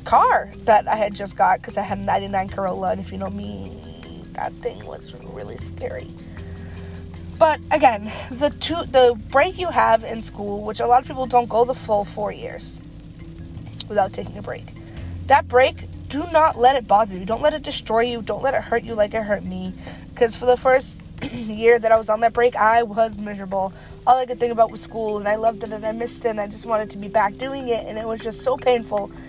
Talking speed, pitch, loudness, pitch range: 230 wpm, 220 Hz, -21 LUFS, 185-240 Hz